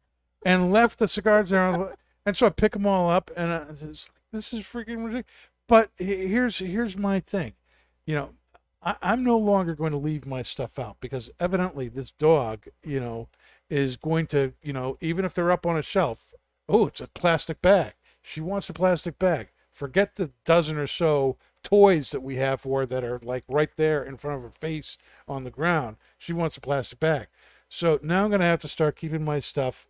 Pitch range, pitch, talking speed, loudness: 135-190 Hz, 160 Hz, 210 wpm, -25 LUFS